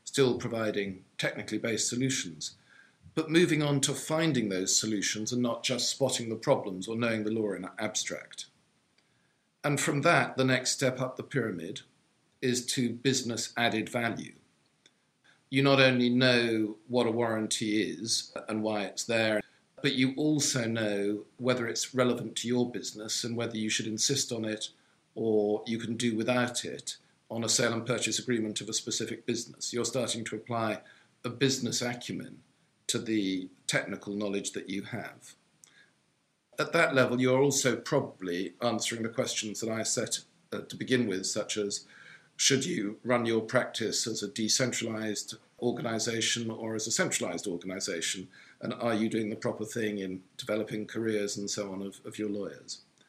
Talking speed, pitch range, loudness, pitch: 165 wpm, 110-125 Hz, -30 LUFS, 115 Hz